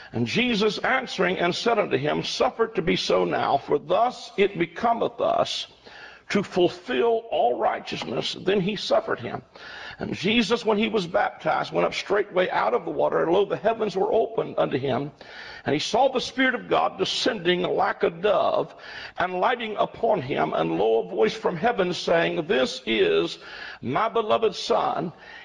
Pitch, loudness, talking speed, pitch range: 220 Hz, -24 LUFS, 170 wpm, 185-240 Hz